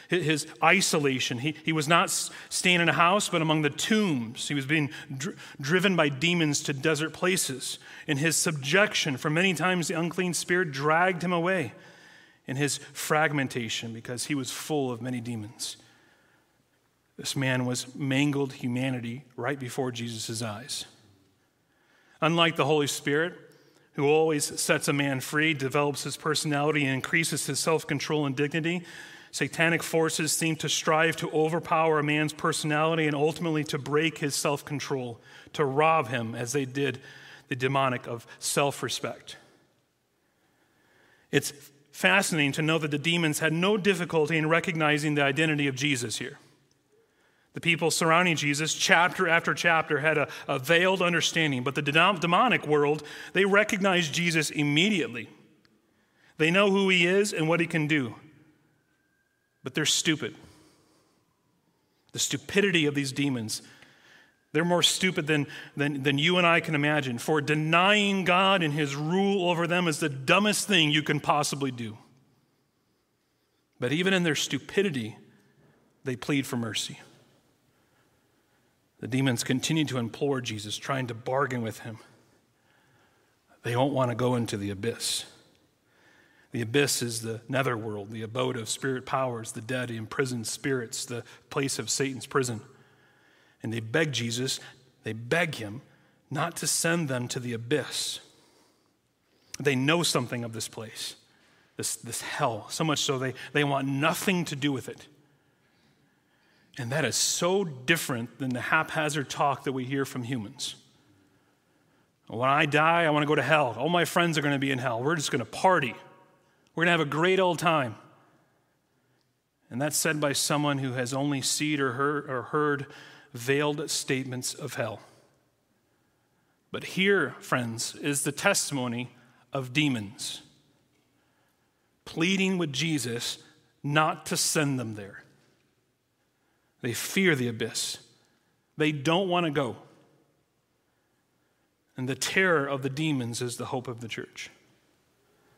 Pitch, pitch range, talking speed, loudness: 150 Hz, 130-165 Hz, 150 wpm, -27 LUFS